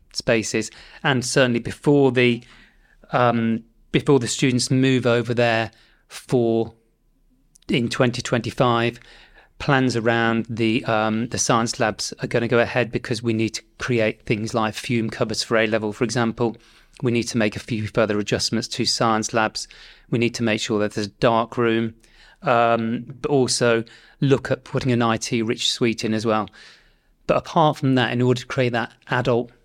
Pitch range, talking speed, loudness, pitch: 115-125 Hz, 175 wpm, -21 LUFS, 115 Hz